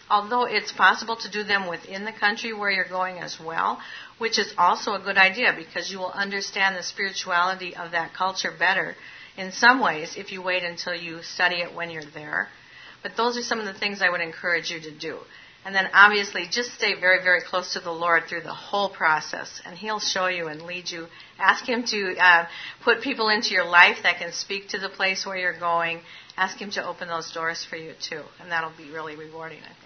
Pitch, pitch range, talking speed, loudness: 185 Hz, 170-200 Hz, 225 wpm, -23 LUFS